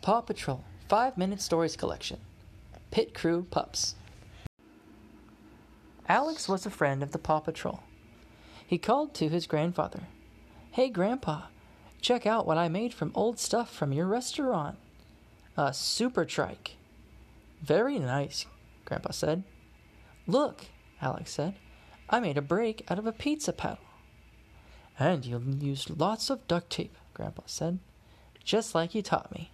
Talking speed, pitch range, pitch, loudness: 140 wpm, 140-220 Hz, 170 Hz, -31 LUFS